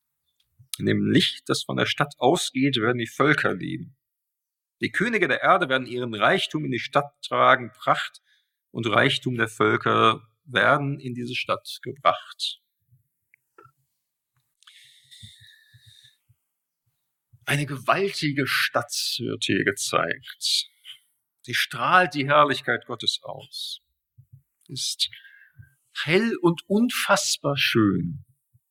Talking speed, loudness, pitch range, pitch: 105 wpm, -23 LUFS, 120-145 Hz, 130 Hz